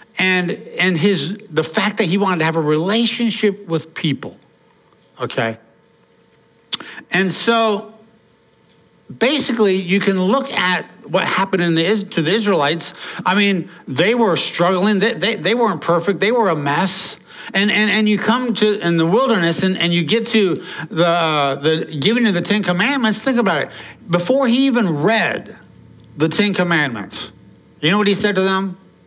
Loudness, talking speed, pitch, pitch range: -17 LUFS, 165 wpm, 190 Hz, 170-215 Hz